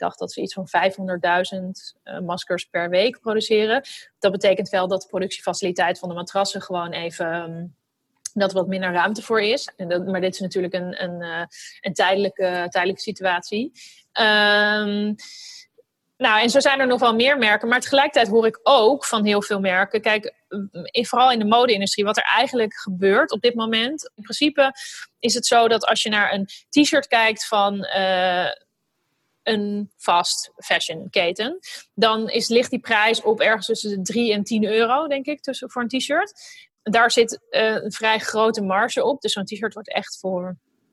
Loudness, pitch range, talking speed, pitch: -20 LUFS, 190-240 Hz, 185 wpm, 215 Hz